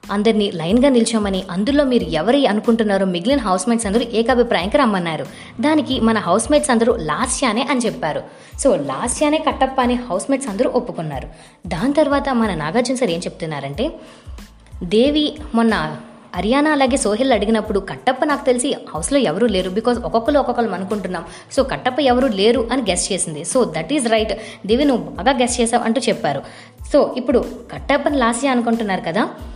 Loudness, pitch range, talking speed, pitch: -18 LUFS, 205-265 Hz, 155 wpm, 235 Hz